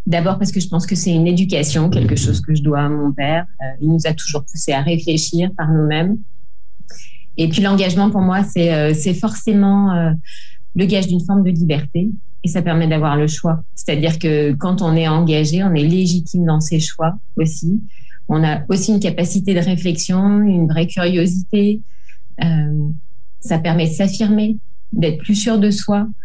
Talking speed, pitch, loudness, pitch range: 190 wpm, 170 Hz, -16 LUFS, 155-190 Hz